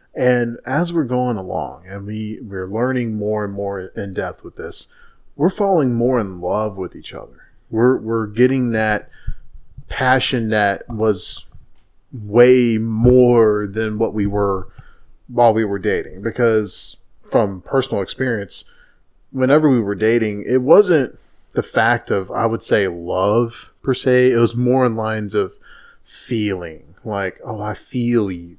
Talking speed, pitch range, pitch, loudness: 150 wpm, 105-125 Hz, 115 Hz, -18 LUFS